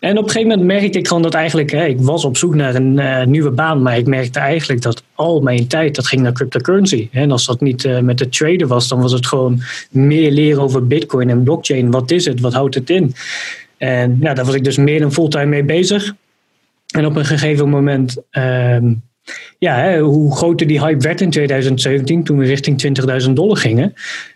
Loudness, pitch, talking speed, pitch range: -14 LUFS, 140 Hz, 225 wpm, 130-160 Hz